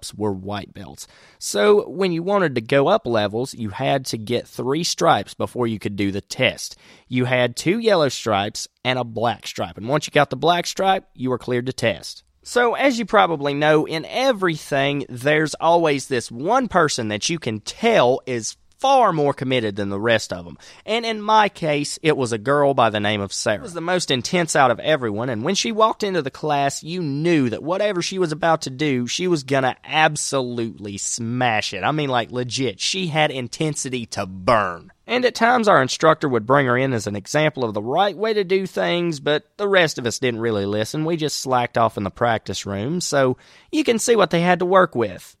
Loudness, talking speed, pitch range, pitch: -20 LUFS, 220 wpm, 120-175 Hz, 140 Hz